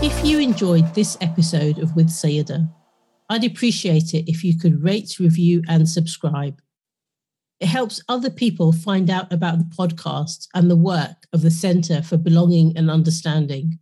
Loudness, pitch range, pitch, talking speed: -19 LUFS, 160-180 Hz, 165 Hz, 160 wpm